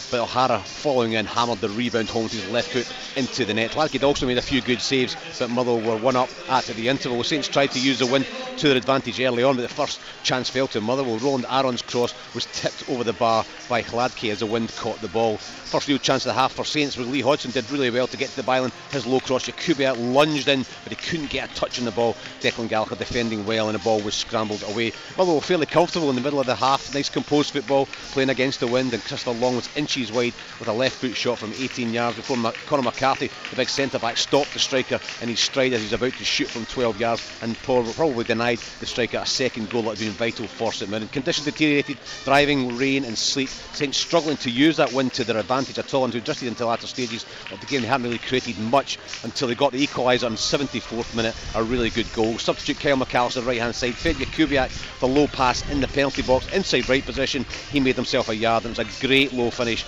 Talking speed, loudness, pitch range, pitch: 245 wpm, -23 LUFS, 115-135 Hz, 125 Hz